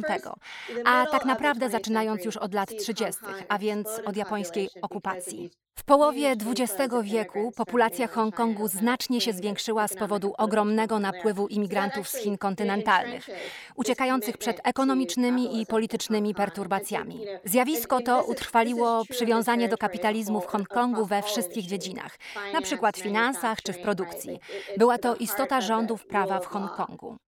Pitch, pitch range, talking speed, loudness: 220 Hz, 205-240 Hz, 135 wpm, -27 LUFS